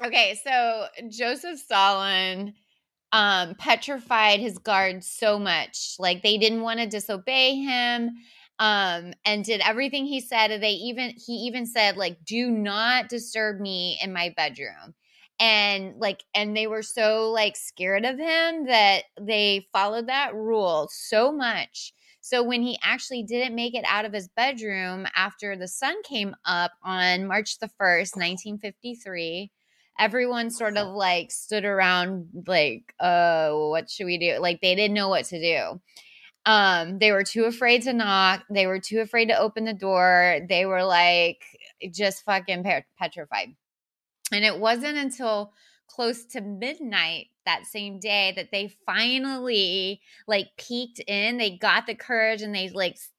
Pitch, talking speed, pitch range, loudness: 210 Hz, 155 wpm, 190-235 Hz, -23 LUFS